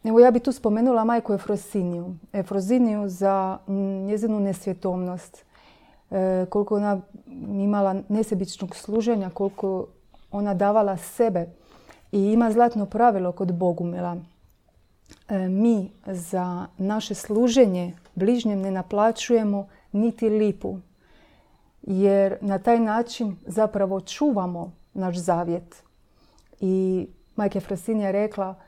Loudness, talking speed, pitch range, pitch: -24 LUFS, 105 wpm, 190-220 Hz, 200 Hz